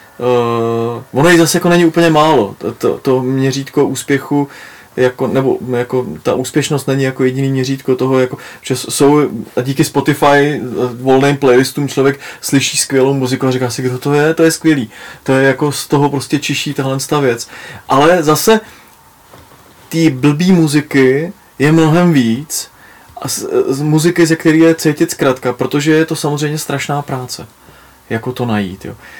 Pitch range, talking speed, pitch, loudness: 130-155 Hz, 165 wpm, 140 Hz, -13 LUFS